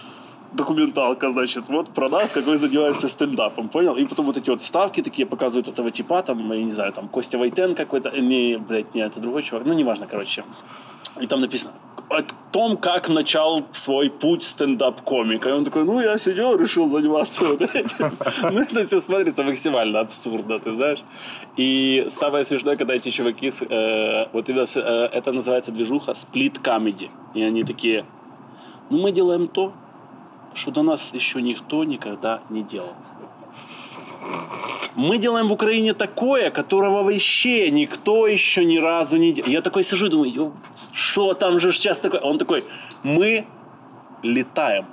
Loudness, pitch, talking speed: -21 LUFS, 160 Hz, 160 wpm